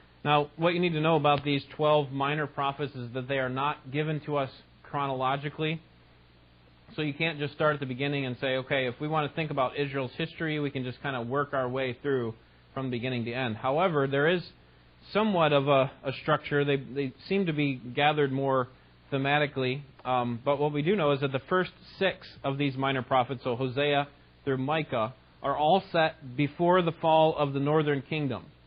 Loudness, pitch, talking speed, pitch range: -29 LUFS, 140 Hz, 205 wpm, 130-150 Hz